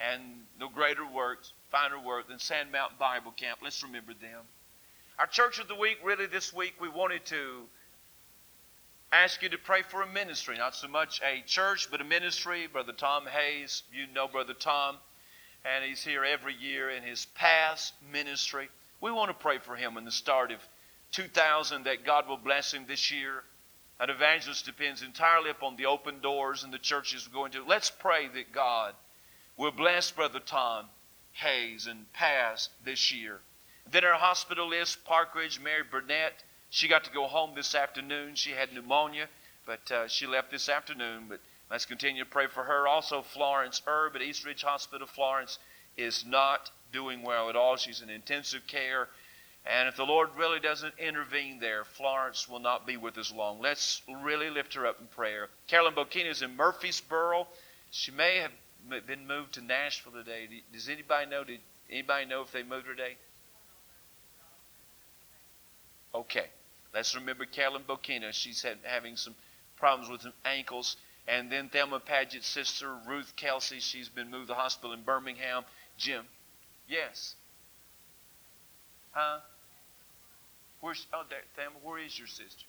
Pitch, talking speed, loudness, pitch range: 140 Hz, 170 wpm, -31 LUFS, 125-150 Hz